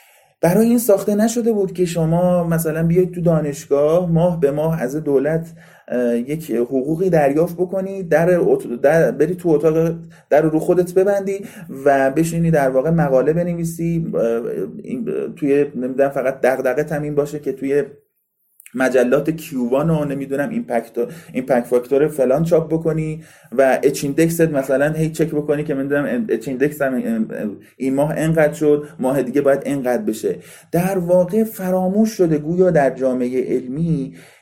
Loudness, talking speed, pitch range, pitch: -18 LUFS, 145 wpm, 140-180 Hz, 155 Hz